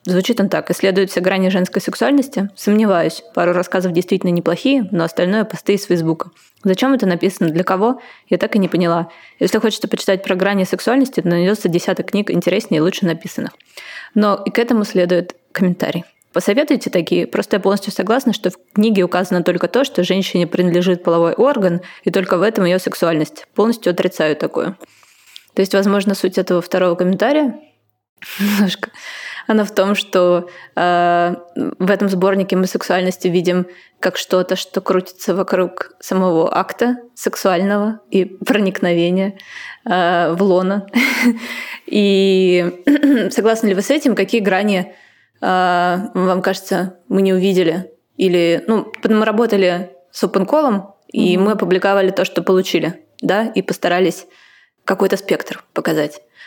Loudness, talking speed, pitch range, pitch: -16 LUFS, 145 wpm, 180-210 Hz, 190 Hz